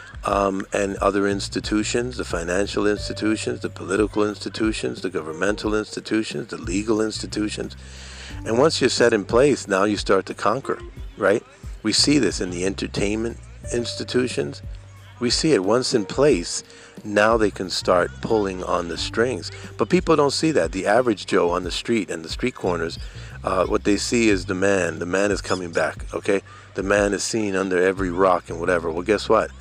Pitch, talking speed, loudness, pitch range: 100 Hz, 180 wpm, -22 LUFS, 95-110 Hz